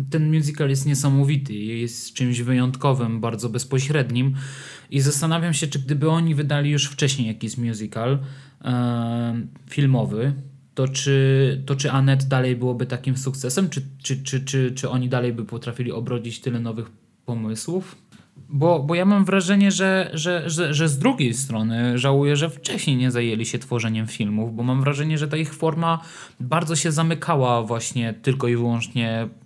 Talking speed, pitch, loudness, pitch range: 160 wpm, 135 Hz, -22 LUFS, 120-150 Hz